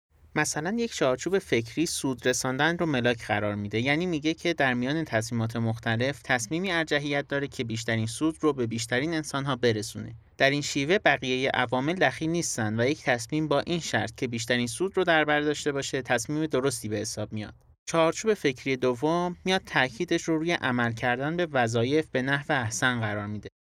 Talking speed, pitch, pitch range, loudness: 185 wpm, 135 Hz, 115-155 Hz, -27 LUFS